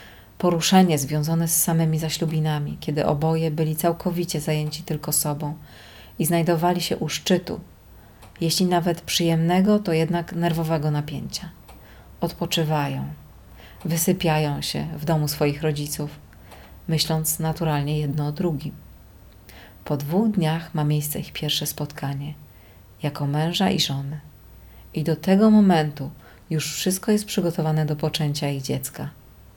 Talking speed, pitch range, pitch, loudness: 120 wpm, 145-170 Hz, 155 Hz, -23 LUFS